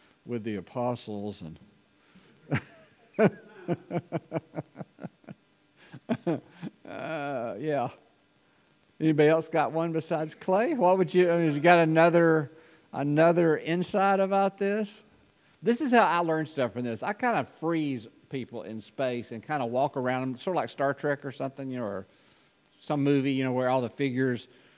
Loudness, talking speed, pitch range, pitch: -27 LUFS, 155 wpm, 125-170 Hz, 145 Hz